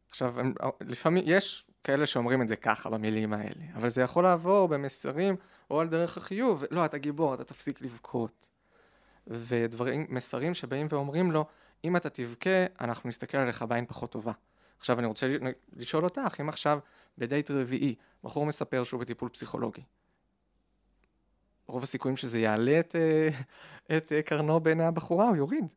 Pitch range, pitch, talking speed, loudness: 120-160 Hz, 140 Hz, 160 wpm, -30 LUFS